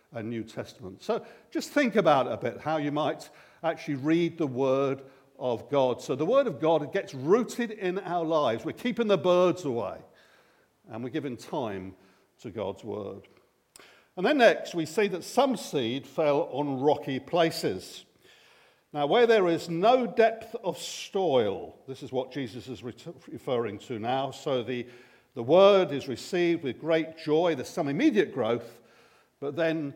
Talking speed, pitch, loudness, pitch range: 165 wpm, 160 Hz, -27 LUFS, 135-195 Hz